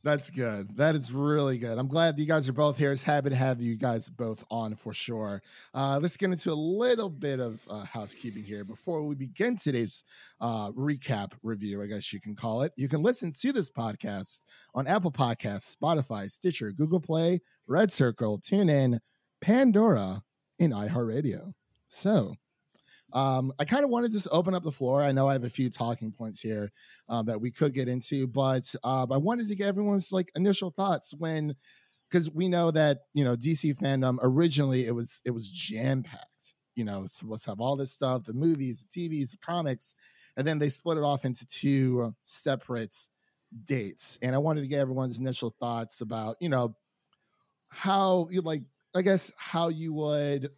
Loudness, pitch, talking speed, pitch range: -29 LUFS, 135 Hz, 190 wpm, 120-165 Hz